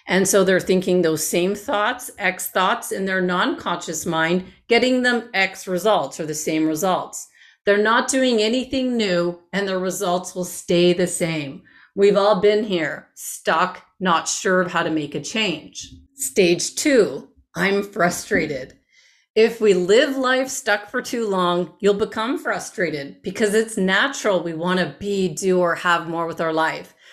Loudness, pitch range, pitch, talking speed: -20 LUFS, 175-215 Hz, 190 Hz, 170 wpm